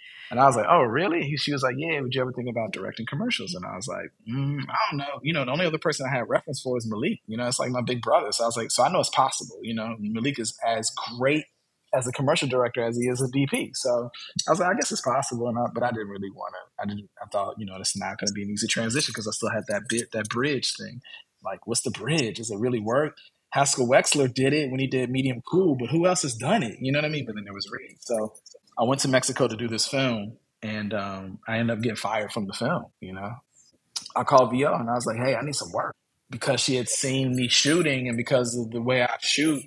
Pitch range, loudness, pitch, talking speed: 115-140 Hz, -25 LUFS, 125 Hz, 280 wpm